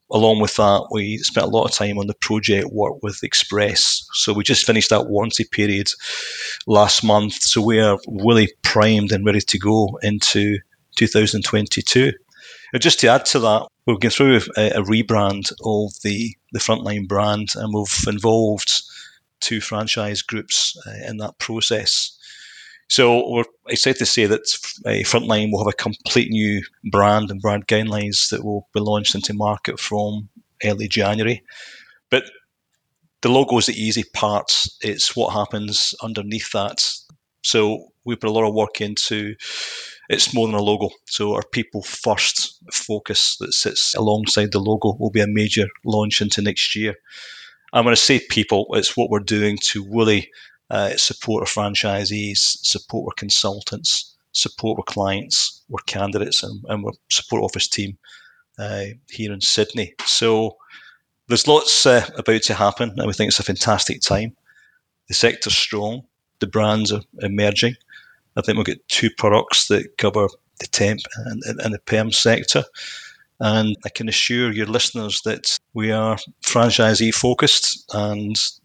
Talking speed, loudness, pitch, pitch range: 160 wpm, -18 LUFS, 105 Hz, 105-110 Hz